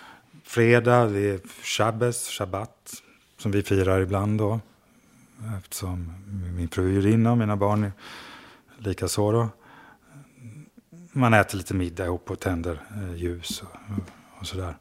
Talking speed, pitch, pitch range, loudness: 120 wpm, 100 Hz, 95-115 Hz, -25 LUFS